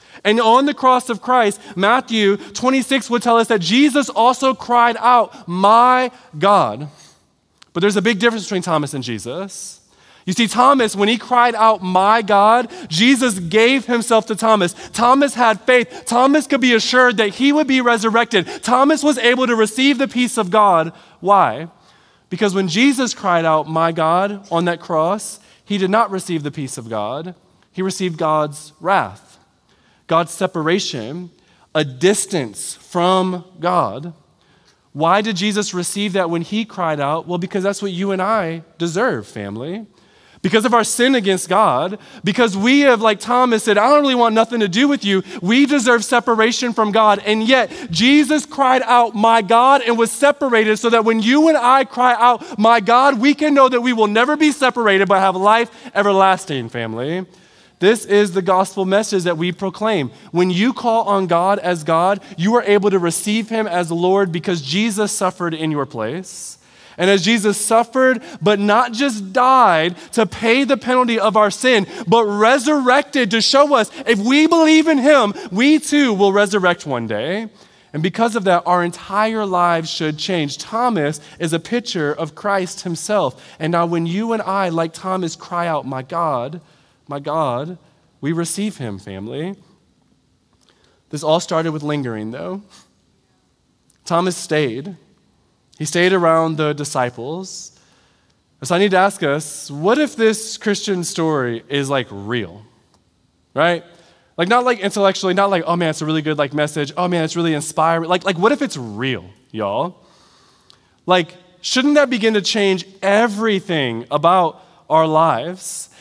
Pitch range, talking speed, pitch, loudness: 170-235 Hz, 170 wpm, 200 Hz, -16 LUFS